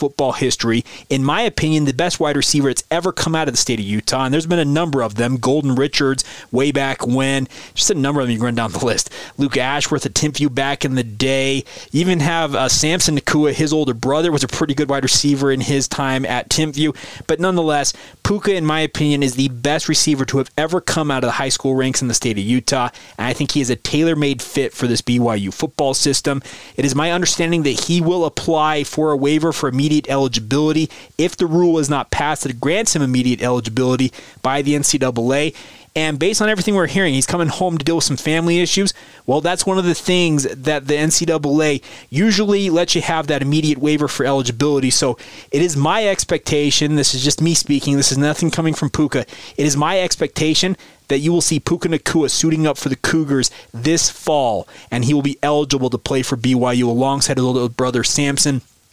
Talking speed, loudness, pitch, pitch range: 220 wpm, -17 LUFS, 145 Hz, 135-160 Hz